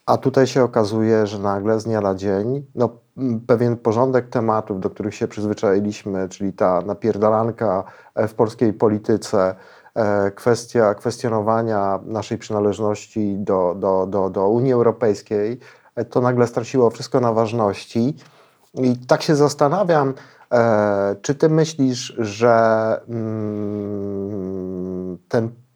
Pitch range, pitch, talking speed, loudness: 100-125 Hz, 110 Hz, 115 wpm, -20 LUFS